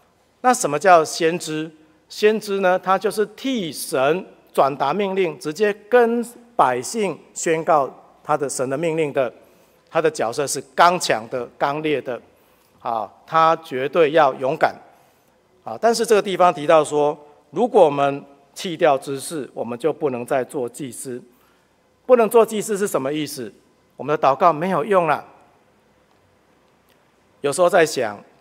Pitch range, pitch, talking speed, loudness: 150-210 Hz, 175 Hz, 215 characters per minute, -20 LUFS